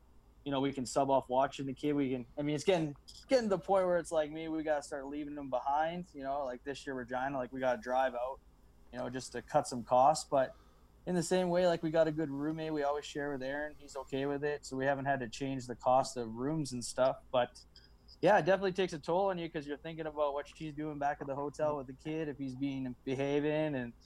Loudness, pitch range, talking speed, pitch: -35 LUFS, 130-155 Hz, 270 wpm, 145 Hz